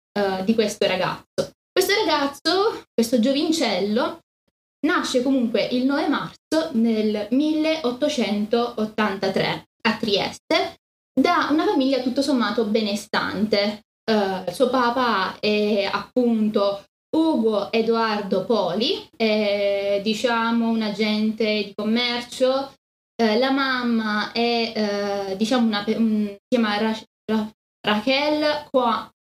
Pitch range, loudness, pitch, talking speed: 210-265 Hz, -22 LUFS, 230 Hz, 100 wpm